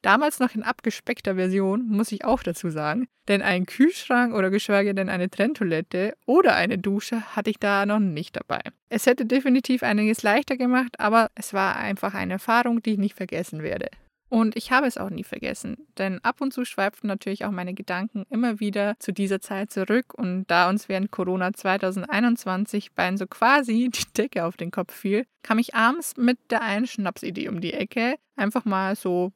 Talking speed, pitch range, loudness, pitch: 190 wpm, 195-240 Hz, -24 LUFS, 210 Hz